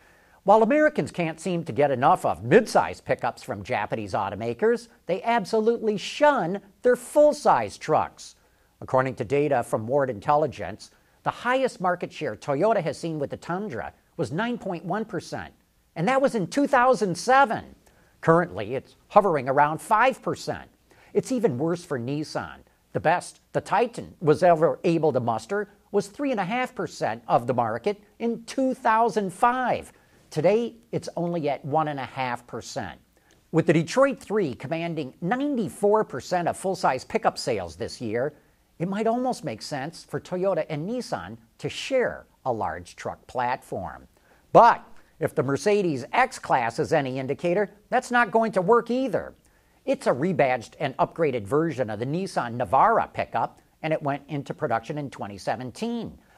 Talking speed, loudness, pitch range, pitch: 145 wpm, -25 LUFS, 145-225 Hz, 175 Hz